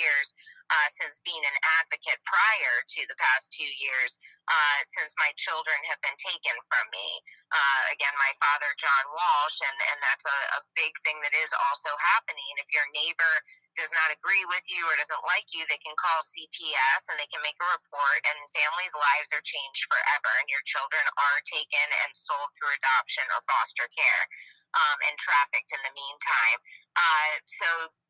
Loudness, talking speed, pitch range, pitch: -26 LUFS, 185 wpm, 145-170 Hz, 155 Hz